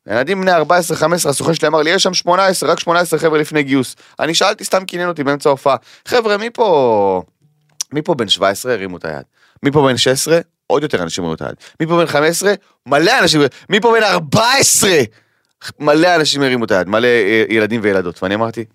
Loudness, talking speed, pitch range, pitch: -14 LUFS, 200 wpm, 115-175 Hz, 150 Hz